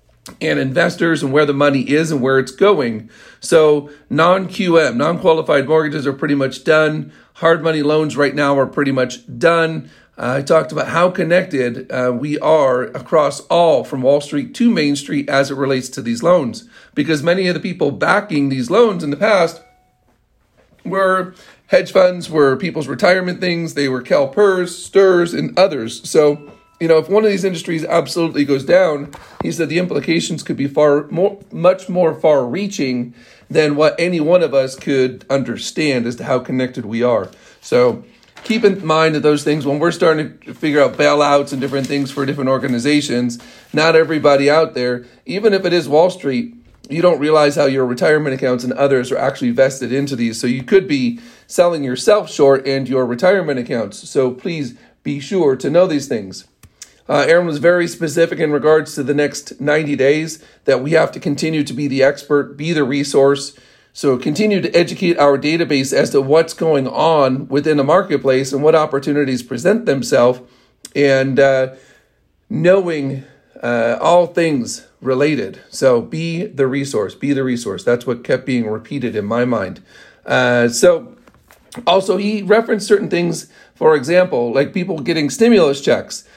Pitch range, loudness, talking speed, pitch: 135-175 Hz, -16 LUFS, 180 wpm, 150 Hz